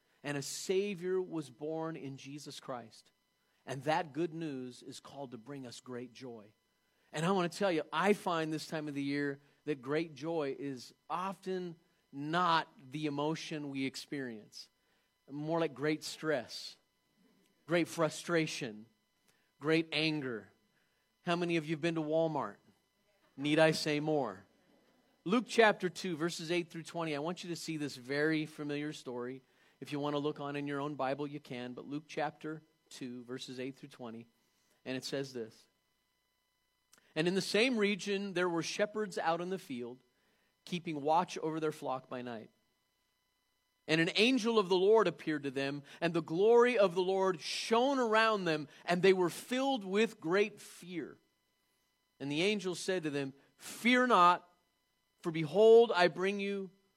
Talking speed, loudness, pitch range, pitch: 165 wpm, -34 LUFS, 140-180 Hz, 155 Hz